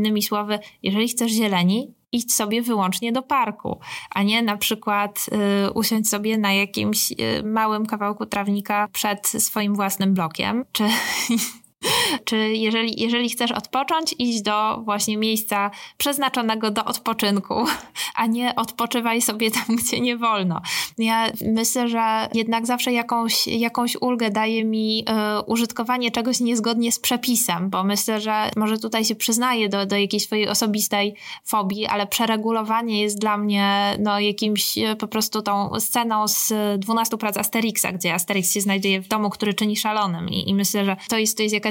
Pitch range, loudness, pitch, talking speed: 205-230 Hz, -21 LUFS, 220 Hz, 160 wpm